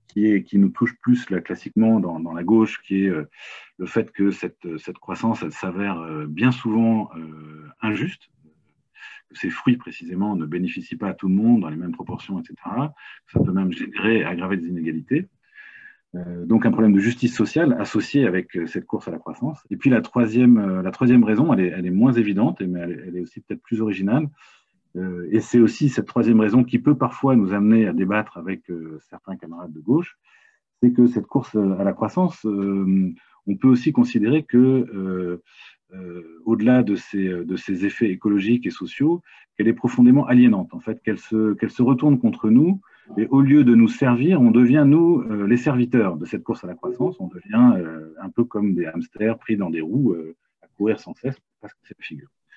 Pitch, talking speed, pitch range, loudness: 110 Hz, 200 wpm, 95-125 Hz, -20 LUFS